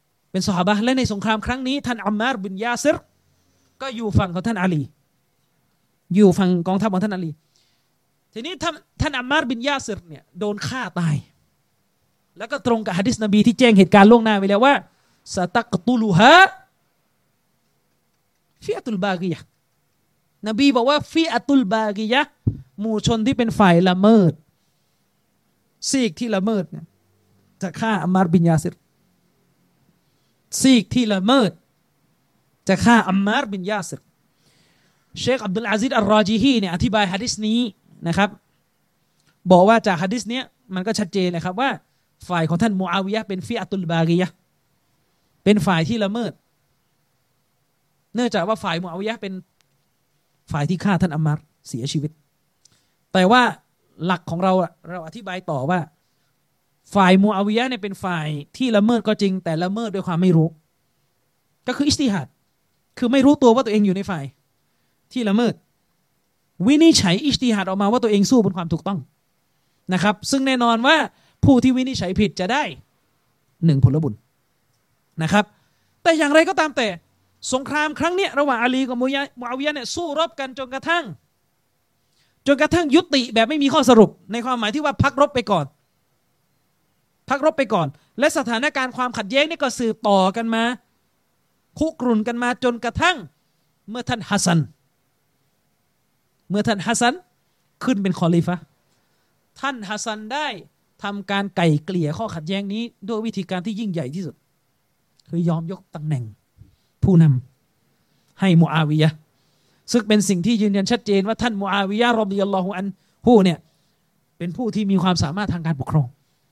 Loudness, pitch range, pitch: -19 LUFS, 175-245 Hz, 205 Hz